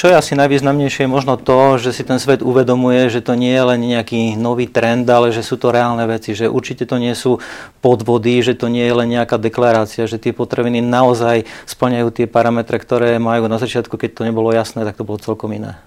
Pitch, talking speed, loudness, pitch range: 120 Hz, 225 wpm, -15 LUFS, 115-125 Hz